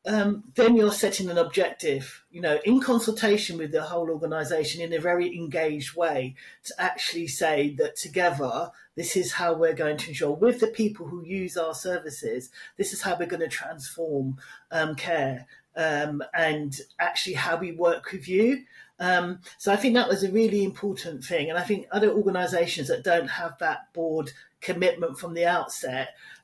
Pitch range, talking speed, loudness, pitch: 160-200 Hz, 180 wpm, -26 LUFS, 175 Hz